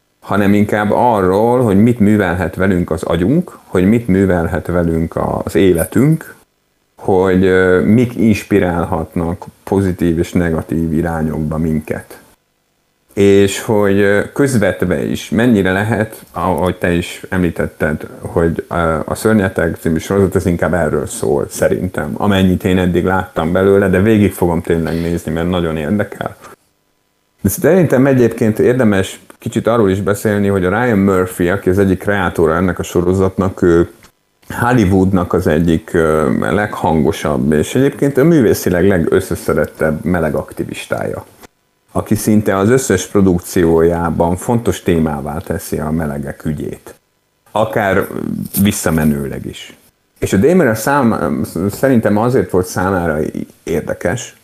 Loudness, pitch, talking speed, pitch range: -14 LUFS, 95 Hz, 120 wpm, 85-100 Hz